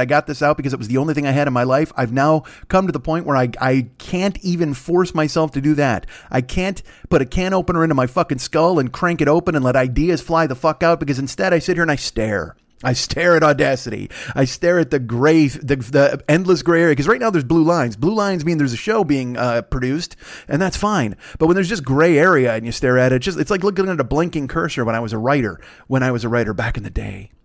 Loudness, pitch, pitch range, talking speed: -18 LUFS, 145 Hz, 130-170 Hz, 275 wpm